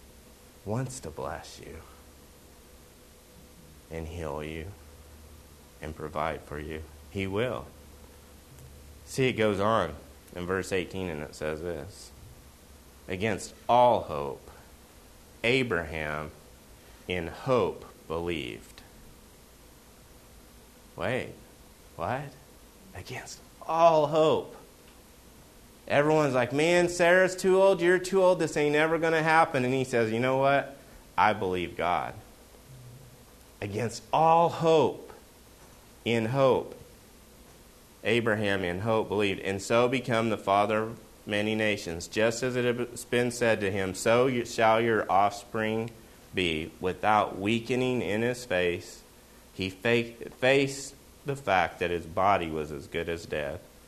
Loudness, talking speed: -27 LUFS, 120 wpm